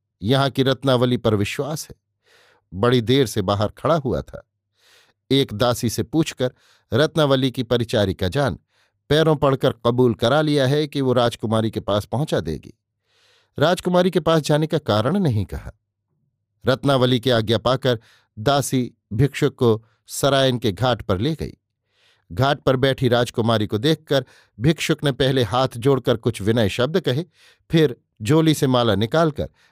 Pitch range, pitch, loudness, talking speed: 110-145 Hz, 125 Hz, -20 LUFS, 155 wpm